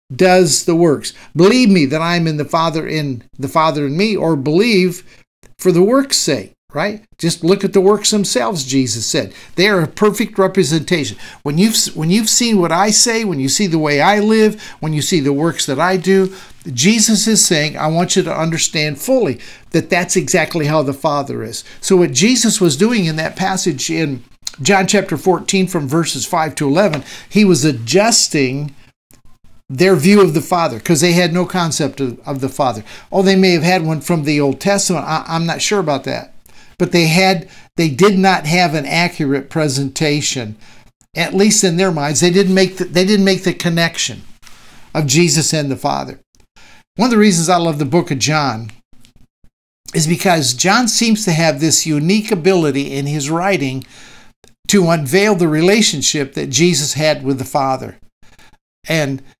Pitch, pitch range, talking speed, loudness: 170 Hz, 145-190 Hz, 190 wpm, -14 LUFS